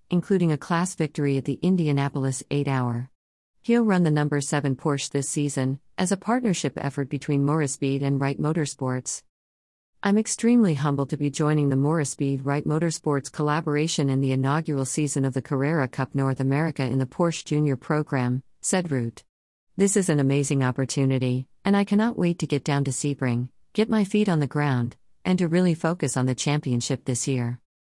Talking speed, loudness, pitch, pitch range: 180 wpm, -24 LUFS, 145 Hz, 135-160 Hz